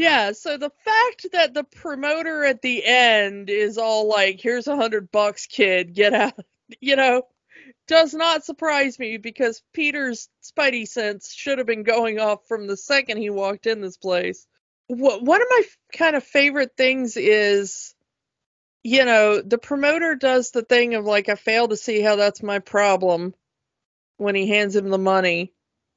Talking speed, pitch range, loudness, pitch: 170 wpm, 205-280 Hz, -20 LUFS, 230 Hz